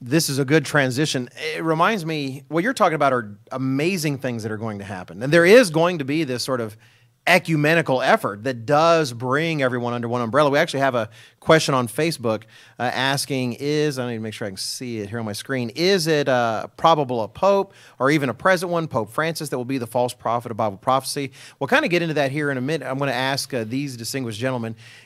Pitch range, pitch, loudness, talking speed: 120-155 Hz, 135 Hz, -21 LUFS, 240 wpm